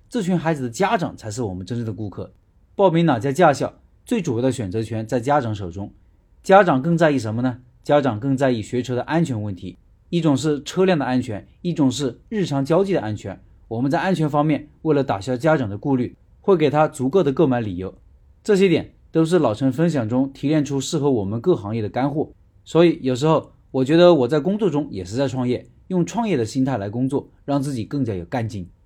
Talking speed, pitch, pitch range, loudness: 325 characters per minute, 135 Hz, 110-160 Hz, -20 LUFS